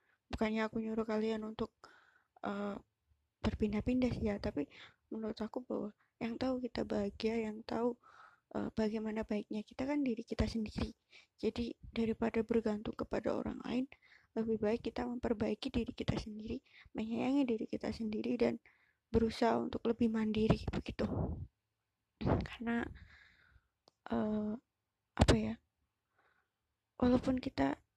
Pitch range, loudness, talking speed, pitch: 215-245 Hz, -38 LUFS, 120 wpm, 225 Hz